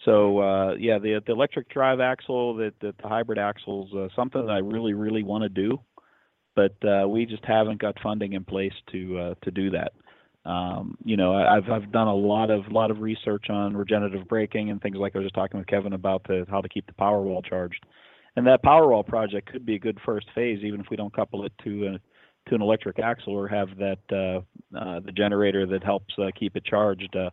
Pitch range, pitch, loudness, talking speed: 95-110 Hz, 100 Hz, -25 LUFS, 235 wpm